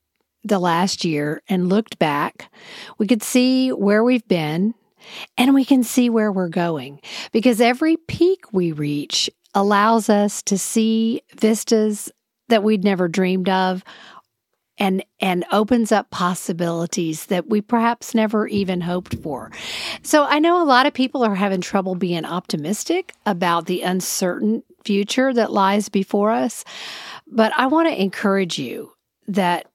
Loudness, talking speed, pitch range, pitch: -19 LUFS, 145 wpm, 185-235 Hz, 210 Hz